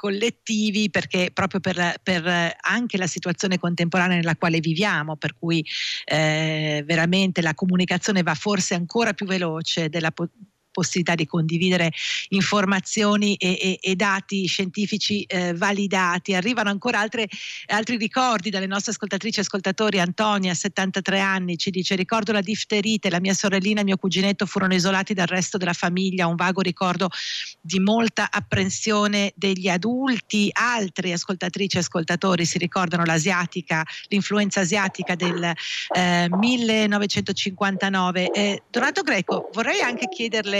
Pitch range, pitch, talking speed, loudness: 175-205 Hz, 190 Hz, 135 wpm, -22 LUFS